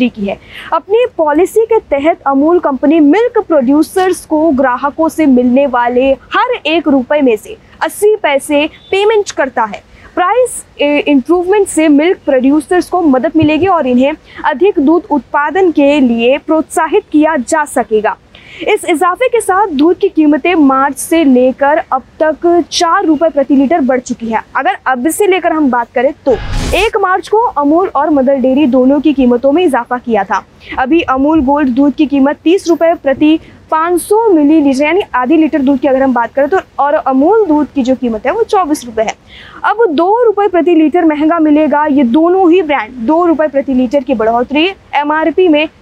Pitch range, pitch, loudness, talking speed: 275-350 Hz, 310 Hz, -10 LUFS, 175 wpm